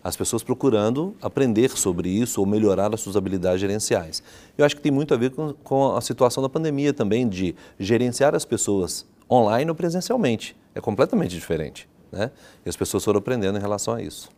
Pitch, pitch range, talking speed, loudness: 120 Hz, 100-140 Hz, 190 wpm, -23 LUFS